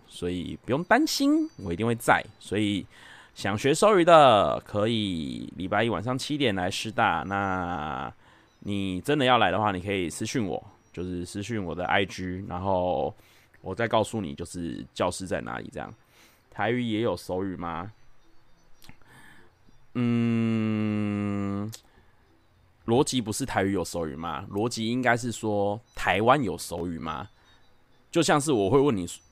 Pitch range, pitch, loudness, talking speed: 90-115 Hz, 105 Hz, -26 LUFS, 215 characters per minute